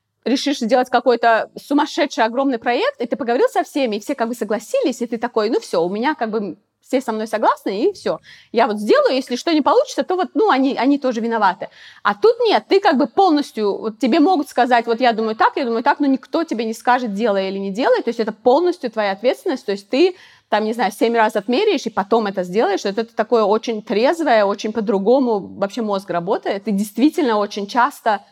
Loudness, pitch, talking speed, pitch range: -18 LUFS, 245 Hz, 225 wpm, 220-290 Hz